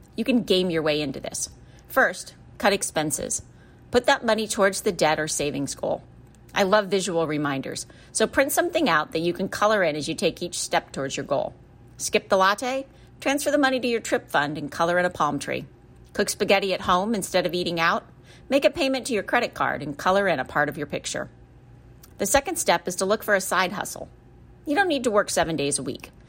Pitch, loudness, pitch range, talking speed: 185 Hz, -24 LUFS, 150-220 Hz, 225 wpm